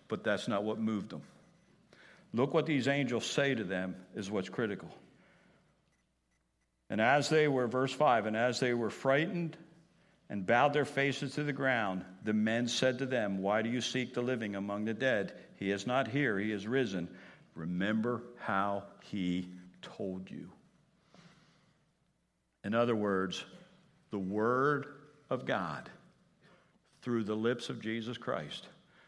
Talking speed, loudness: 150 wpm, -33 LUFS